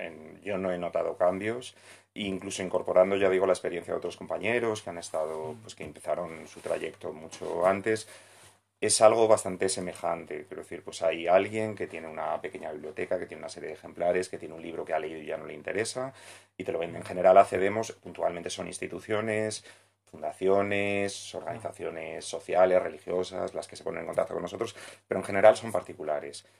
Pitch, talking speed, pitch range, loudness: 100 Hz, 185 wpm, 90-110 Hz, -29 LUFS